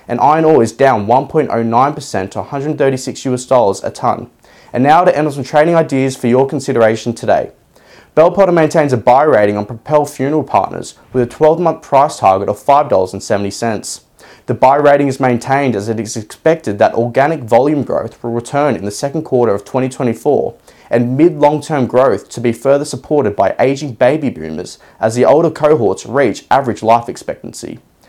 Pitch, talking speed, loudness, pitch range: 130 Hz, 175 wpm, -13 LUFS, 115-150 Hz